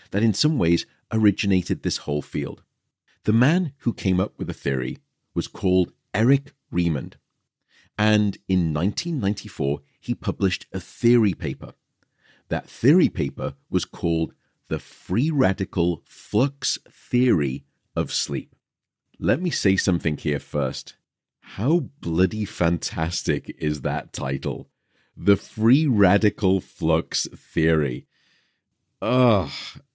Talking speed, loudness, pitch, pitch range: 115 wpm, -23 LUFS, 100 Hz, 85-120 Hz